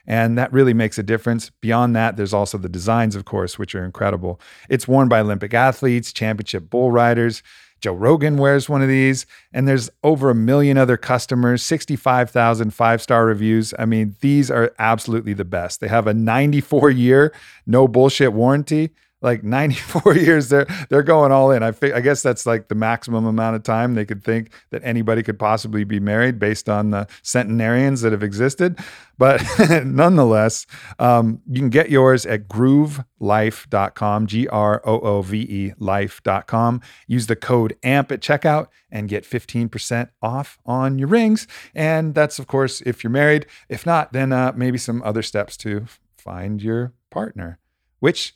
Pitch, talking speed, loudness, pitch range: 120 Hz, 170 wpm, -18 LUFS, 110-135 Hz